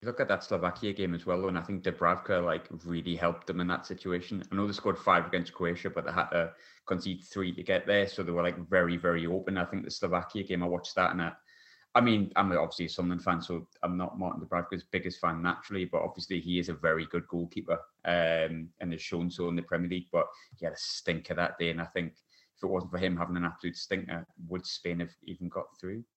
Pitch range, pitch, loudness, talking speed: 85-95 Hz, 90 Hz, -32 LUFS, 250 wpm